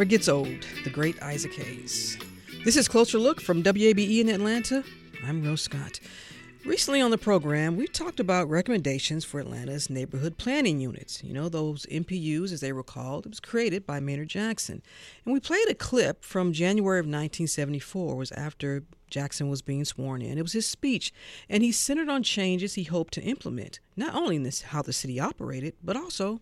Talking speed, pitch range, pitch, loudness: 190 wpm, 140-220 Hz, 165 Hz, -28 LUFS